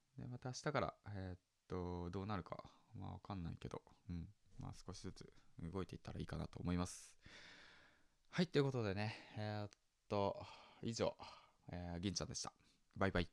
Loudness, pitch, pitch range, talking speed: -46 LUFS, 95 Hz, 90-105 Hz, 345 characters per minute